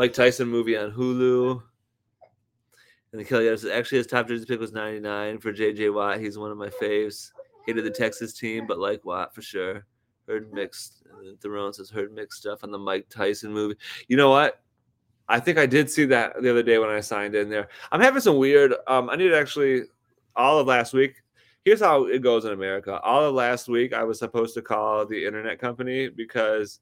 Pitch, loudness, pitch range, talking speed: 115 Hz, -23 LUFS, 105-130 Hz, 210 wpm